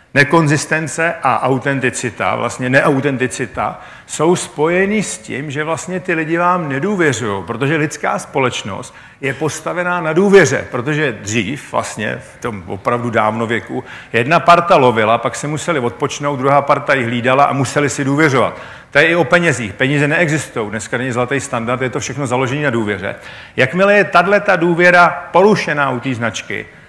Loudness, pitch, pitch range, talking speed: -15 LUFS, 145 Hz, 125-170 Hz, 155 wpm